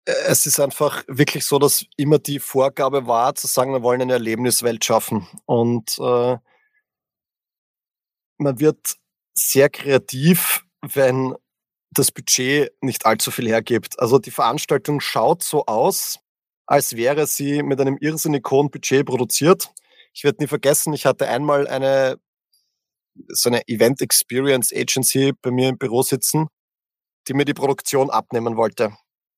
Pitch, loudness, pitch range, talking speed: 135 Hz, -19 LUFS, 130-145 Hz, 140 wpm